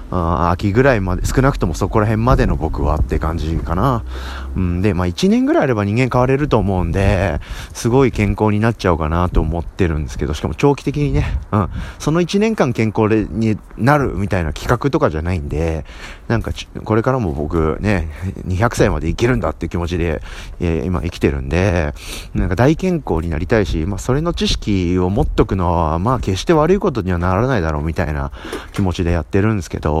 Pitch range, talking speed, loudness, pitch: 85-120 Hz, 410 characters per minute, -17 LUFS, 95 Hz